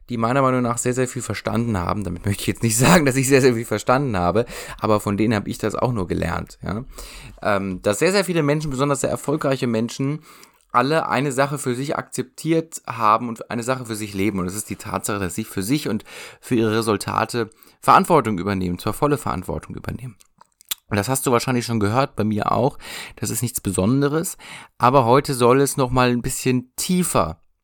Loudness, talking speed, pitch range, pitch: -21 LUFS, 210 wpm, 105-135 Hz, 120 Hz